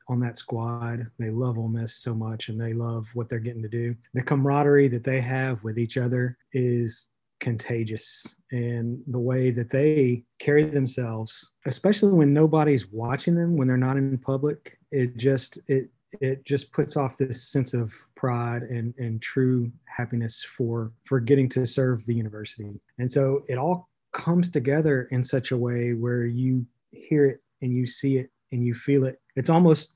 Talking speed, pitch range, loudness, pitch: 180 wpm, 120-135 Hz, -25 LUFS, 125 Hz